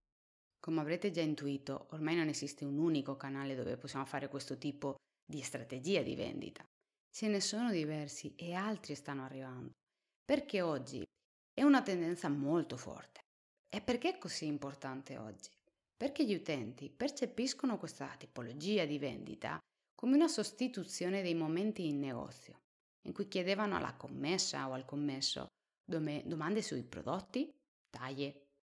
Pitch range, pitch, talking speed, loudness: 140-200 Hz, 155 Hz, 140 wpm, -39 LUFS